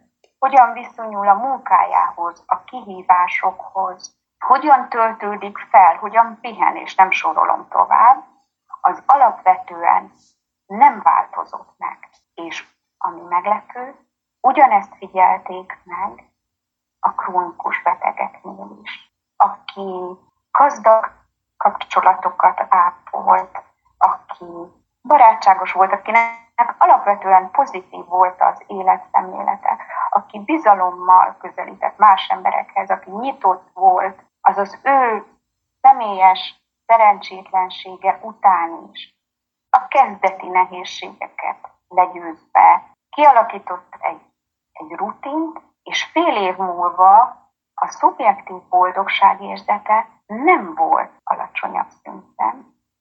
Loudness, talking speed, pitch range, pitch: -16 LUFS, 90 wpm, 185-255 Hz, 200 Hz